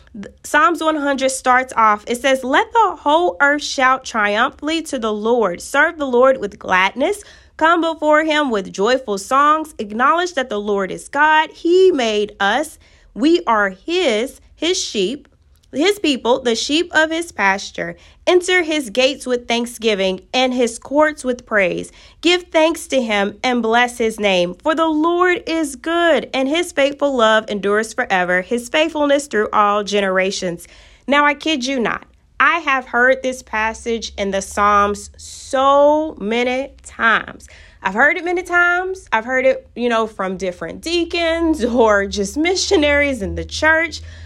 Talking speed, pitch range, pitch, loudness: 155 wpm, 215-315 Hz, 260 Hz, -17 LUFS